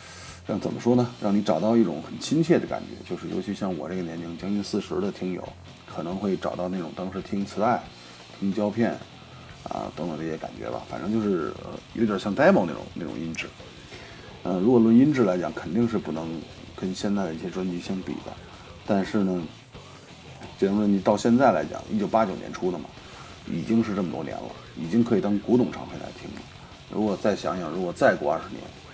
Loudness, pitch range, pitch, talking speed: -26 LUFS, 85-110 Hz, 100 Hz, 315 characters per minute